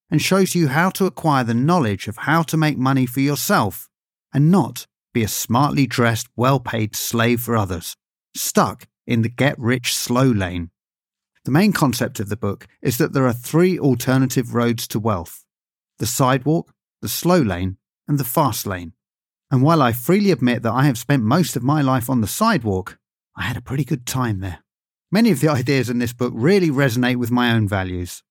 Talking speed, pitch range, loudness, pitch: 195 wpm, 115-150 Hz, -19 LUFS, 130 Hz